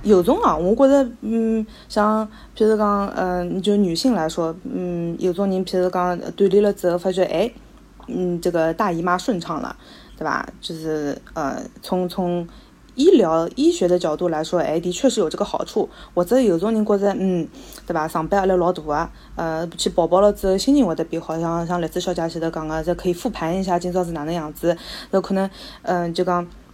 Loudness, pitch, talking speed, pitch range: -21 LUFS, 180 Hz, 290 characters per minute, 170-205 Hz